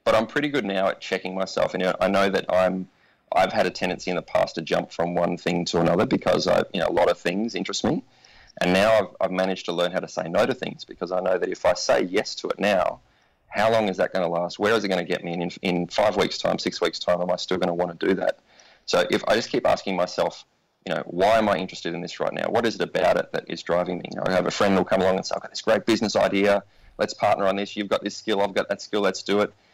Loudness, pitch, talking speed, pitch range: -24 LUFS, 90 Hz, 310 wpm, 85-100 Hz